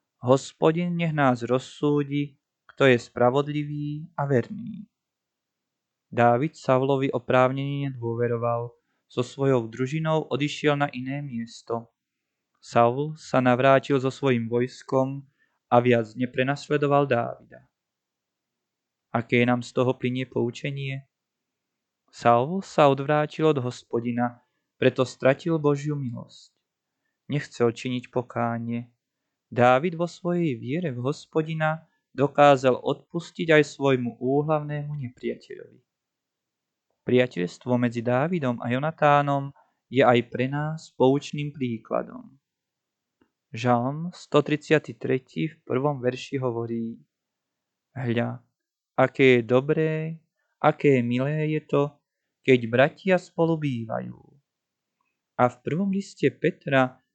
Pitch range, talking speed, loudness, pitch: 125-150 Hz, 100 wpm, -25 LUFS, 135 Hz